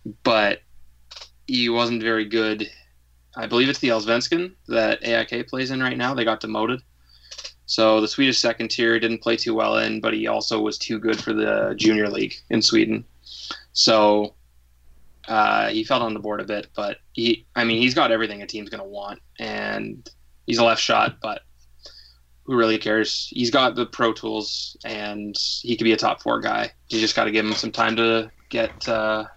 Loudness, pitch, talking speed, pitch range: -21 LUFS, 110 Hz, 195 wpm, 85-115 Hz